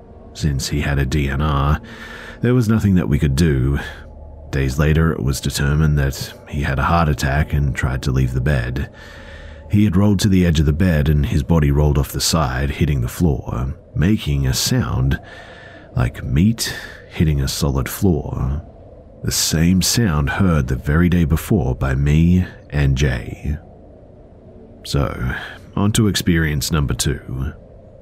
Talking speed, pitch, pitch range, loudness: 160 wpm, 75 Hz, 70-90 Hz, -18 LUFS